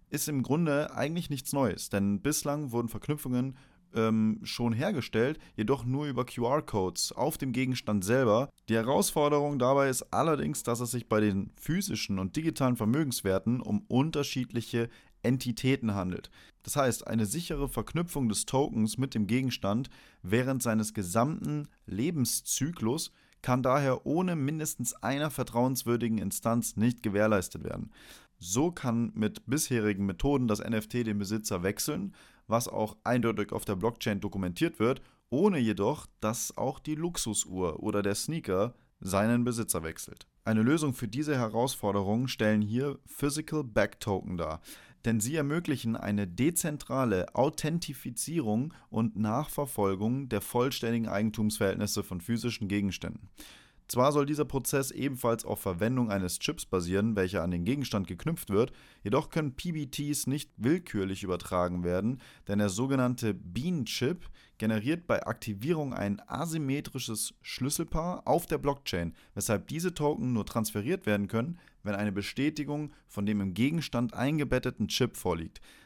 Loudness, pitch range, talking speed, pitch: -31 LUFS, 105-140 Hz, 135 wpm, 120 Hz